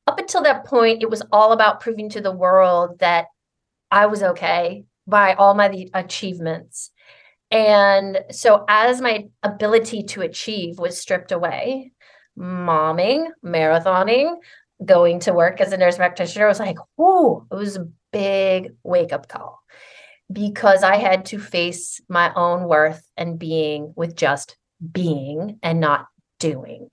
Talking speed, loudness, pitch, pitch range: 145 wpm, -18 LUFS, 195 Hz, 175-215 Hz